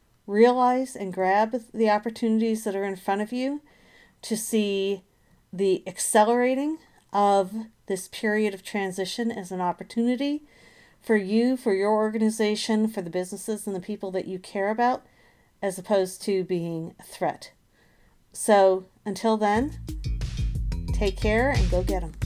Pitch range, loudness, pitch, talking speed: 195-225 Hz, -25 LUFS, 210 Hz, 145 wpm